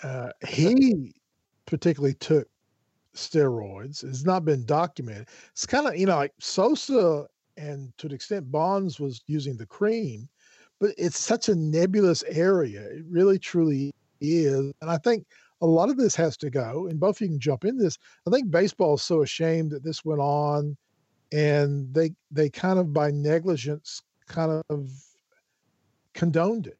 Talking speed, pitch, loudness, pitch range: 165 wpm, 155 Hz, -25 LUFS, 145-180 Hz